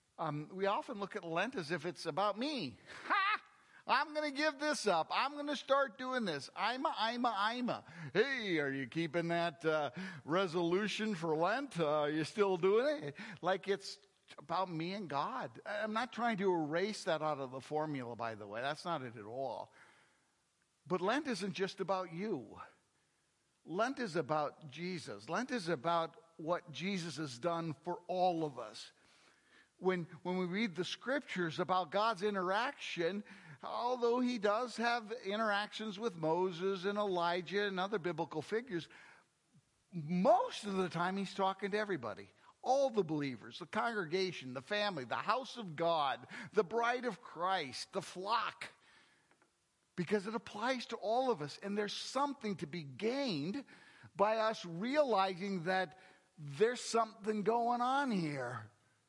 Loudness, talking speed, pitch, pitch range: -37 LUFS, 160 wpm, 190 Hz, 170-220 Hz